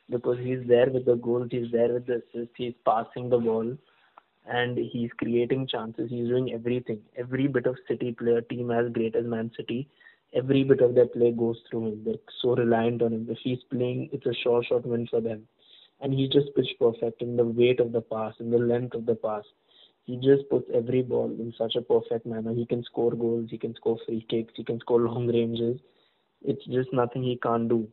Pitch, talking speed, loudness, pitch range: 120 Hz, 220 wpm, -27 LUFS, 115-125 Hz